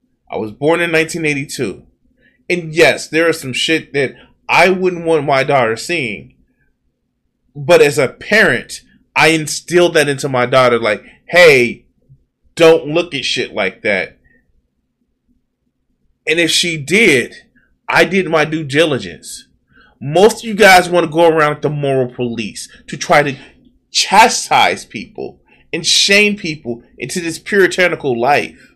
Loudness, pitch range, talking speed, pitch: -13 LUFS, 140-175 Hz, 145 wpm, 160 Hz